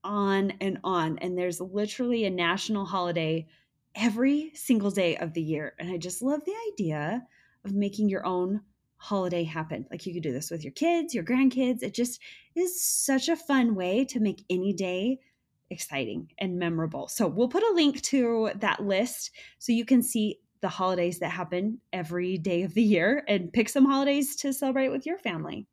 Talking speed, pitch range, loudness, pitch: 190 wpm, 180-260 Hz, -28 LUFS, 205 Hz